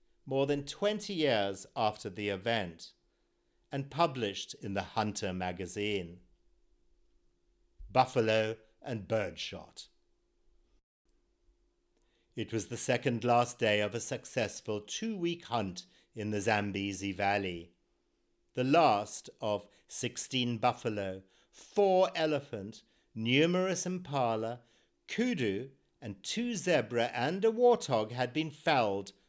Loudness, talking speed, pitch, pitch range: -33 LUFS, 105 wpm, 115 Hz, 100-140 Hz